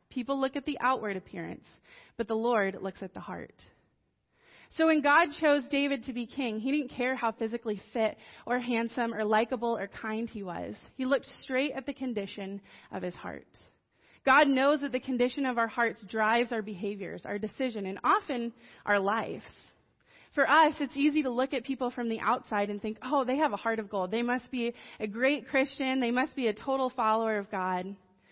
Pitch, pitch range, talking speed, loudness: 240 Hz, 215-270 Hz, 200 wpm, -30 LUFS